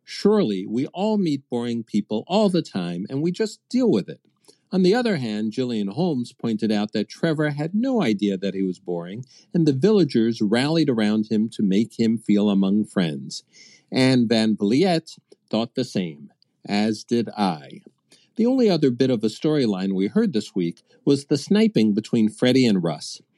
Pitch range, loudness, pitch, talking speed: 105-170 Hz, -22 LUFS, 120 Hz, 180 wpm